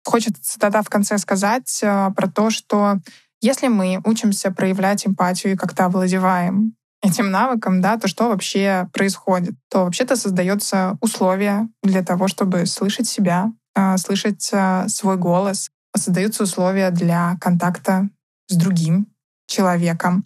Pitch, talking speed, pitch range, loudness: 195 Hz, 125 wpm, 185-210 Hz, -19 LUFS